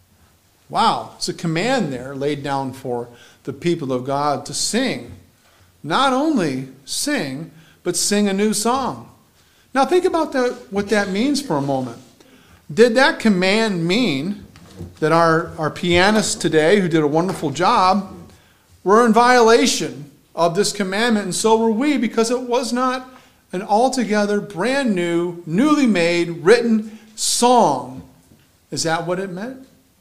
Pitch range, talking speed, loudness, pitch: 150-240 Hz, 145 wpm, -18 LUFS, 190 Hz